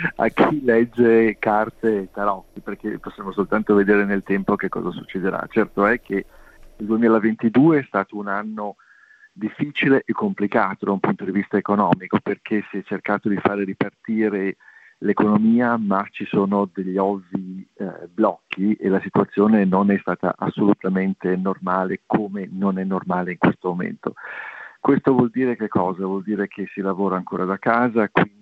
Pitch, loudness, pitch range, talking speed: 100 Hz, -21 LUFS, 95-110 Hz, 160 wpm